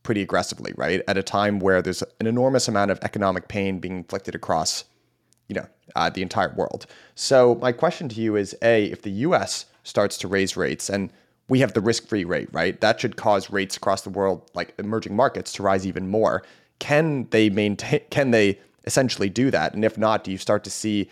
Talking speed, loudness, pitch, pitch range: 210 wpm, -23 LUFS, 105 Hz, 95-115 Hz